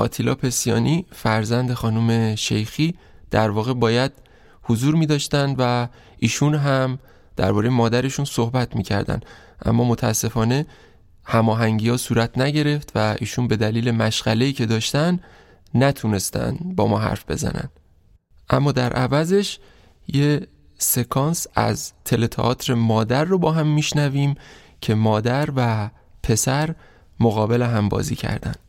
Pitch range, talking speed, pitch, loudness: 110-140 Hz, 120 wpm, 120 Hz, -21 LUFS